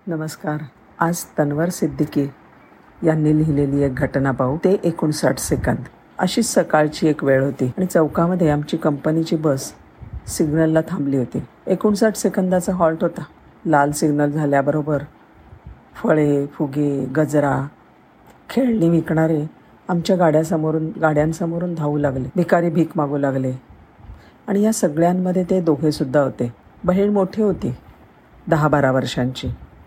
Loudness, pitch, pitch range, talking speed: -19 LUFS, 155 Hz, 140-170 Hz, 120 wpm